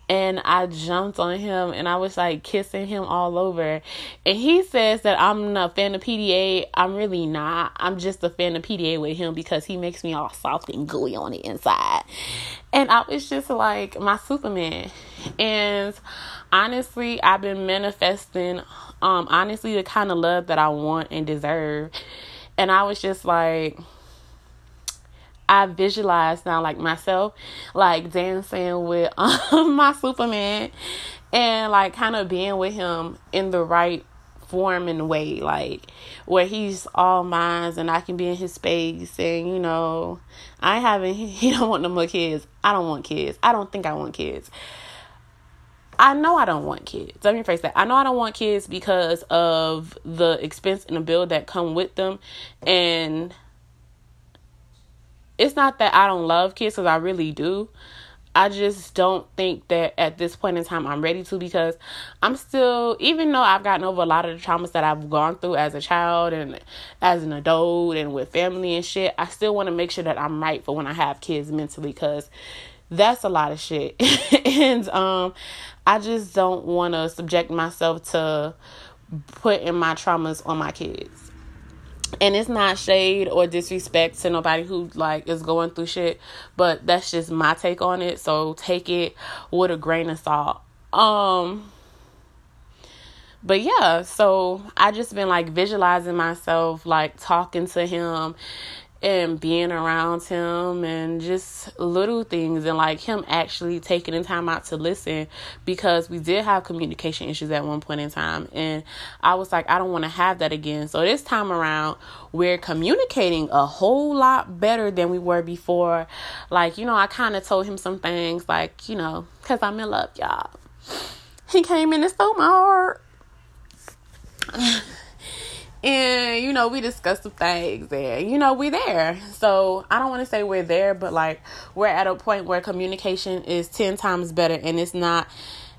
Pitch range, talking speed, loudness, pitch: 160-195 Hz, 180 wpm, -22 LUFS, 175 Hz